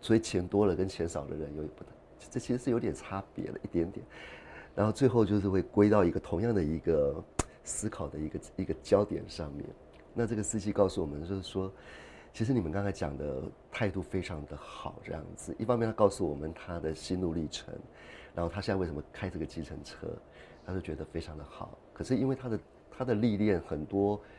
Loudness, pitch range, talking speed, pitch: -33 LUFS, 80-110 Hz, 315 characters per minute, 95 Hz